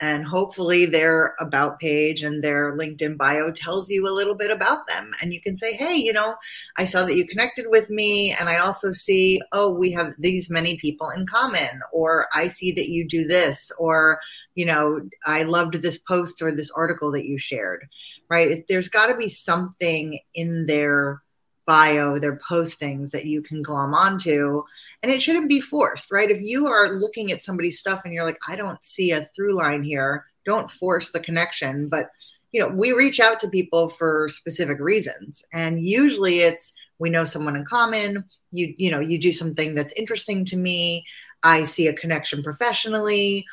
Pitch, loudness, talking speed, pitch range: 170 Hz, -21 LUFS, 190 wpm, 155-195 Hz